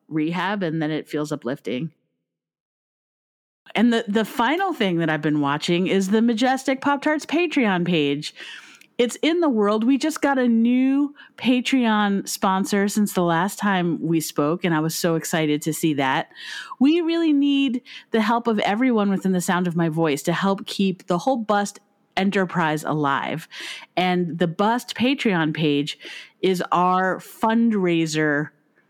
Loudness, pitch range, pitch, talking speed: -21 LUFS, 160-235 Hz, 190 Hz, 160 wpm